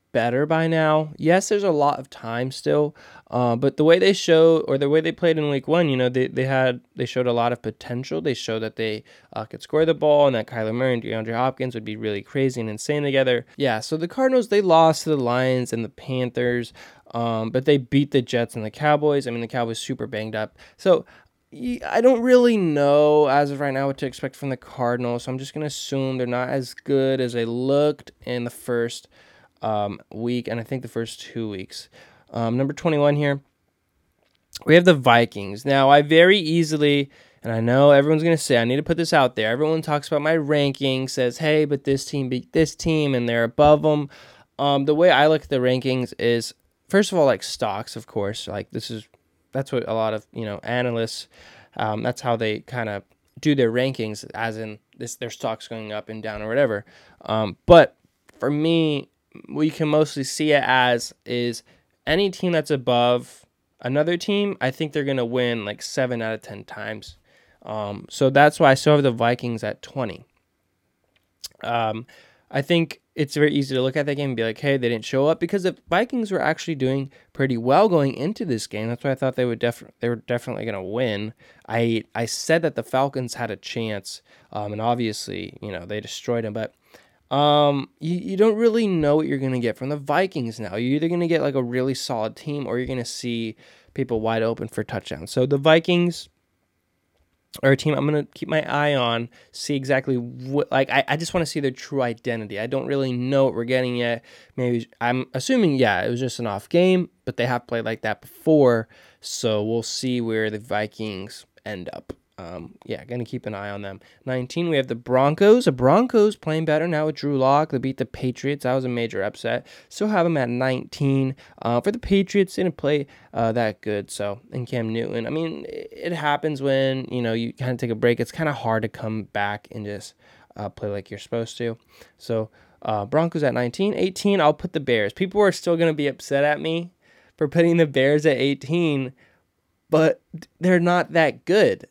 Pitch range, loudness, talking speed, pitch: 115-150 Hz, -22 LUFS, 215 wpm, 130 Hz